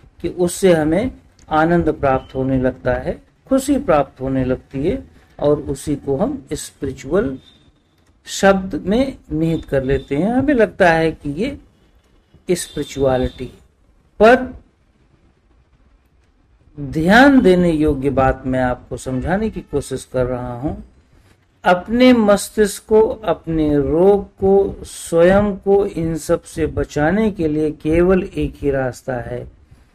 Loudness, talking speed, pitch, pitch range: -17 LUFS, 125 wpm, 155 Hz, 130-190 Hz